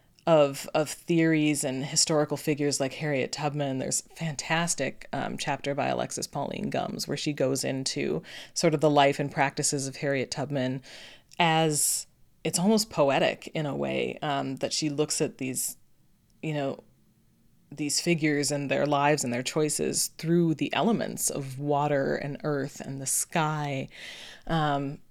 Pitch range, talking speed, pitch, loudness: 135-155 Hz, 155 wpm, 145 Hz, -27 LUFS